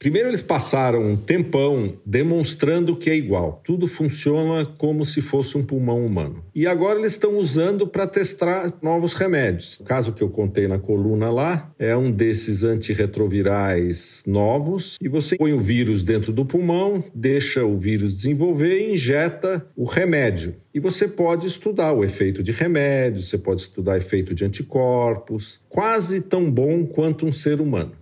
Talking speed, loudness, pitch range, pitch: 165 wpm, -21 LUFS, 105-170 Hz, 140 Hz